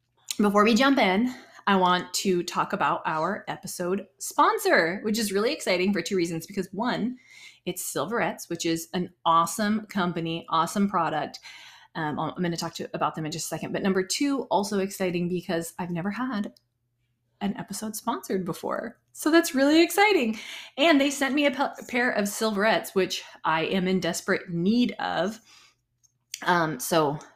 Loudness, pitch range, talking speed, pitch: -26 LUFS, 170-230 Hz, 170 wpm, 190 Hz